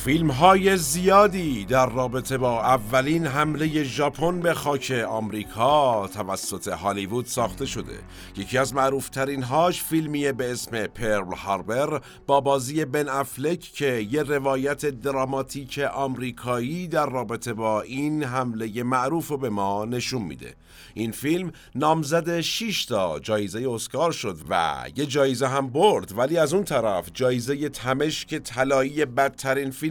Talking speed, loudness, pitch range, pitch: 135 wpm, -24 LUFS, 120-150 Hz, 135 Hz